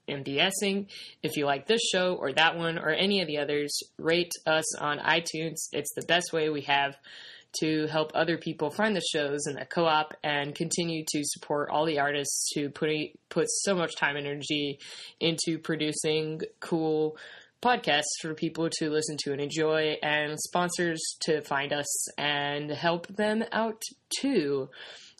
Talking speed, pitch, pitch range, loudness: 165 wpm, 155 Hz, 145-170 Hz, -28 LUFS